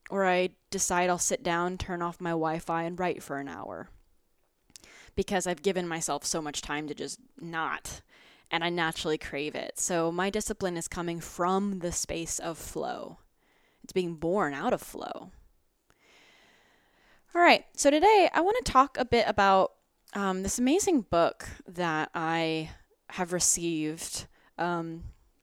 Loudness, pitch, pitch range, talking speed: -28 LUFS, 175 Hz, 165-200 Hz, 155 wpm